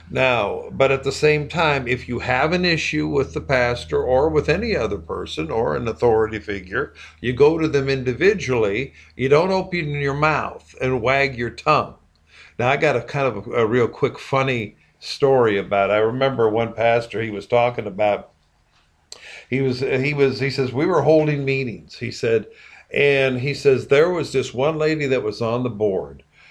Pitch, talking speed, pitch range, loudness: 135 Hz, 190 wpm, 120-150 Hz, -20 LUFS